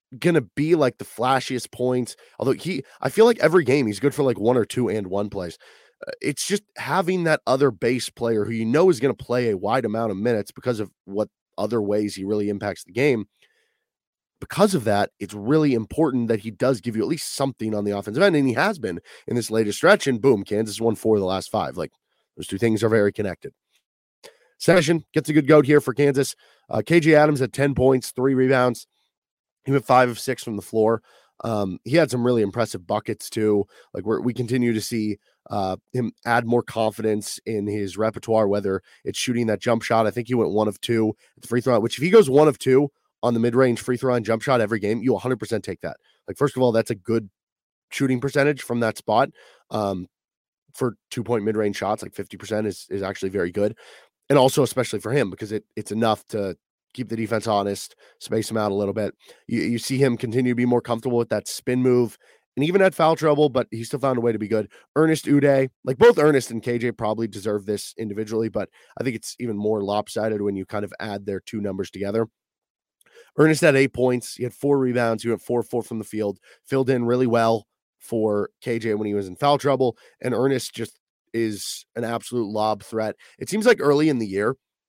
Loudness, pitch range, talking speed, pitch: -22 LUFS, 105-130 Hz, 225 wpm, 115 Hz